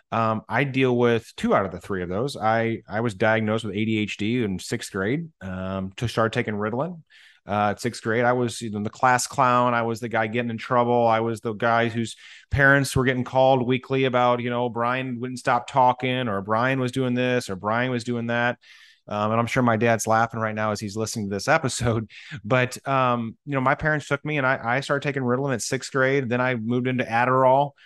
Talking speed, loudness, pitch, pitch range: 230 wpm, -23 LUFS, 120 Hz, 110-130 Hz